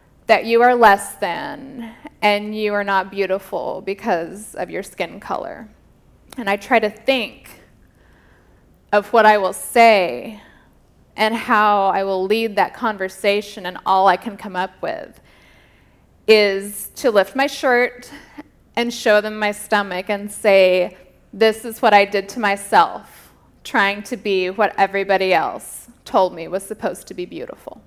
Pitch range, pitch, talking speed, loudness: 195-225 Hz, 205 Hz, 155 wpm, -18 LUFS